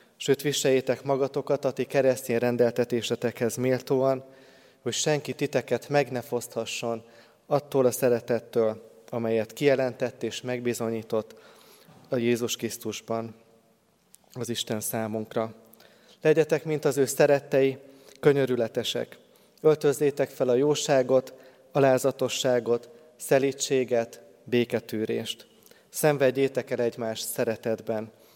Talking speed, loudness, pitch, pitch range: 95 wpm, -26 LUFS, 125 Hz, 115-135 Hz